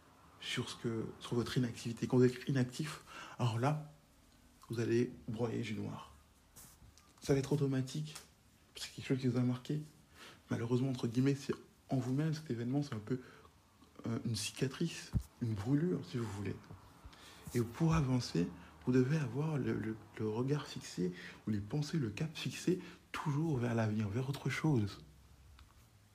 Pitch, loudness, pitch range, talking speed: 125 Hz, -38 LUFS, 110-145 Hz, 165 wpm